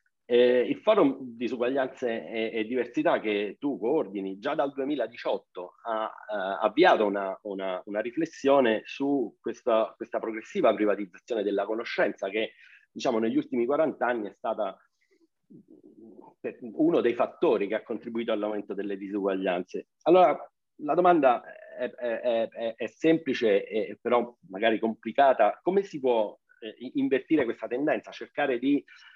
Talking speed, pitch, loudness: 135 wpm, 120 Hz, -27 LUFS